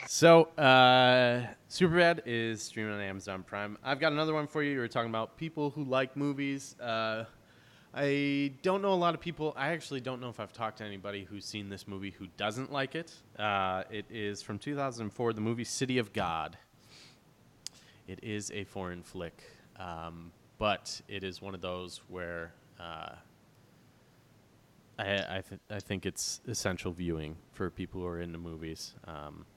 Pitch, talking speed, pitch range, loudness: 110 Hz, 170 wpm, 95-135 Hz, -32 LUFS